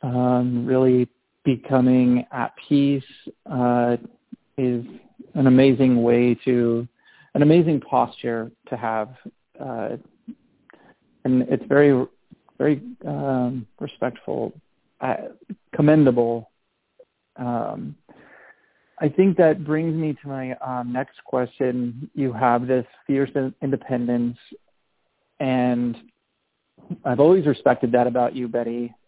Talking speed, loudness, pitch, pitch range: 100 wpm, -21 LUFS, 125 Hz, 120-140 Hz